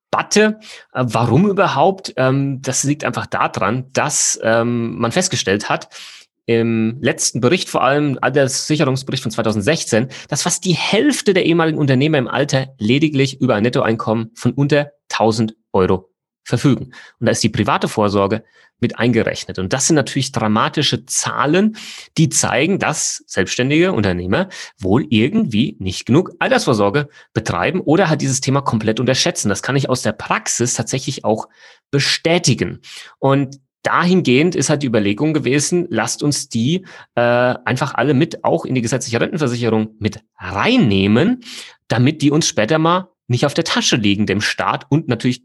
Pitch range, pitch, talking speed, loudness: 115-155 Hz, 130 Hz, 150 wpm, -17 LUFS